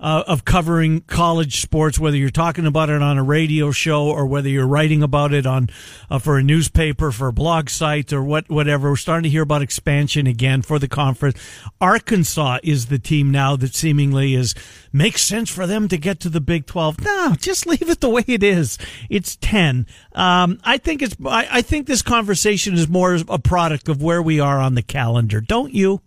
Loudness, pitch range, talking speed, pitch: -18 LUFS, 140-180 Hz, 210 wpm, 155 Hz